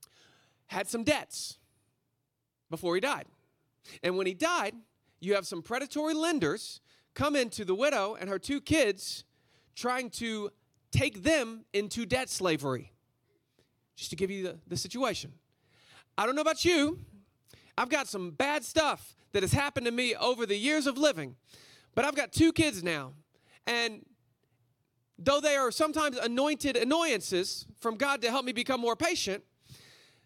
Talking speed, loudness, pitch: 155 wpm, -30 LUFS, 225 Hz